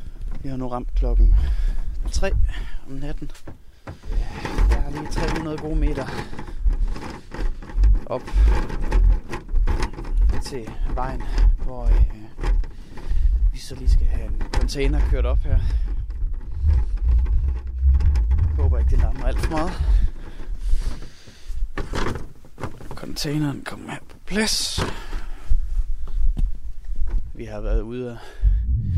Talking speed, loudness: 95 wpm, -25 LUFS